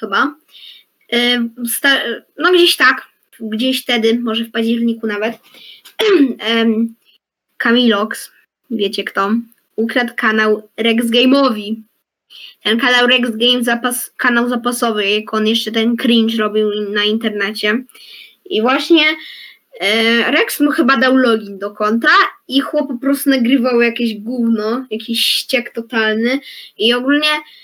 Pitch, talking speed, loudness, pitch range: 235 Hz, 120 wpm, -14 LUFS, 220-260 Hz